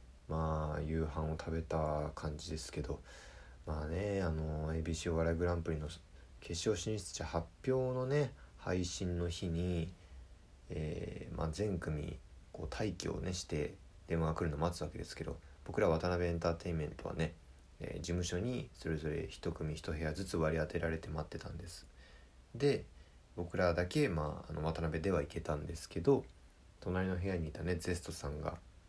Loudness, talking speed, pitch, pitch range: -39 LUFS, 315 characters per minute, 85 Hz, 75-90 Hz